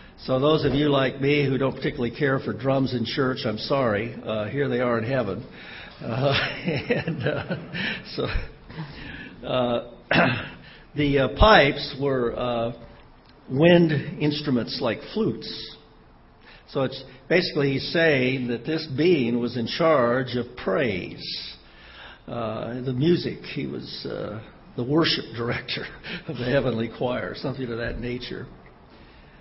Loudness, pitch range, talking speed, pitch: -24 LUFS, 120-145 Hz, 135 wpm, 130 Hz